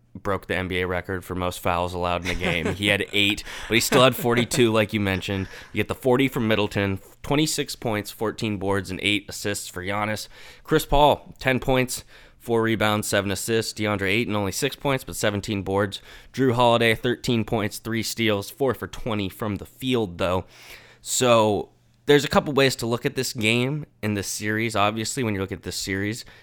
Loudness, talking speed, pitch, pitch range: -23 LUFS, 200 wpm, 105 Hz, 100-120 Hz